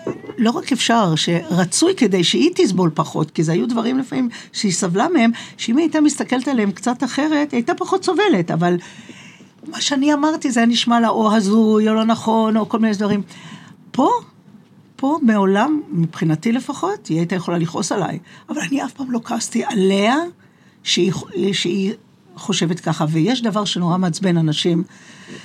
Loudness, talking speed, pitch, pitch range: -18 LUFS, 165 wpm, 215 Hz, 180-255 Hz